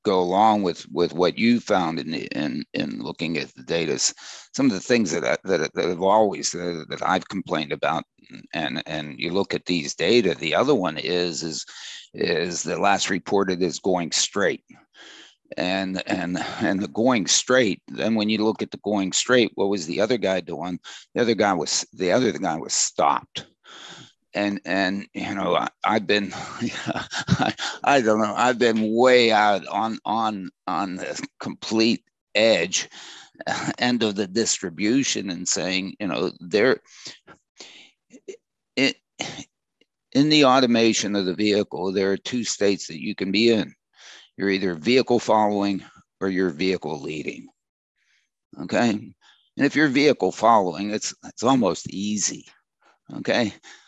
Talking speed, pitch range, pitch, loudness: 160 wpm, 95-115 Hz, 100 Hz, -23 LUFS